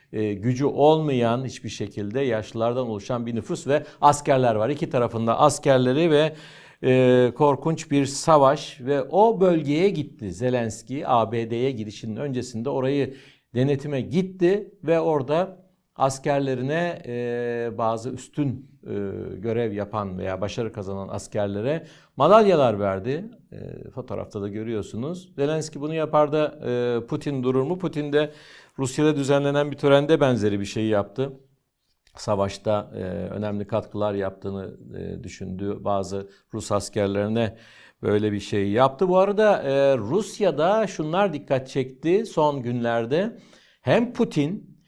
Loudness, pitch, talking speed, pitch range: -23 LUFS, 130 Hz, 120 wpm, 110-150 Hz